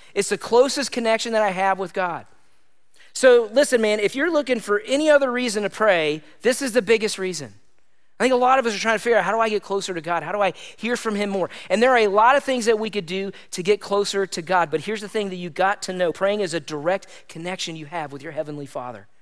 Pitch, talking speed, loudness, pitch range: 205 Hz, 270 wpm, -21 LUFS, 180-235 Hz